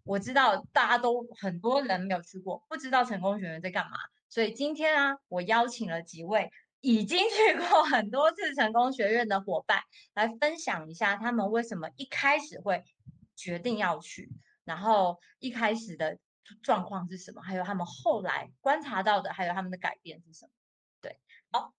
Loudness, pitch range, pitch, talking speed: -29 LUFS, 185-255 Hz, 215 Hz, 275 characters per minute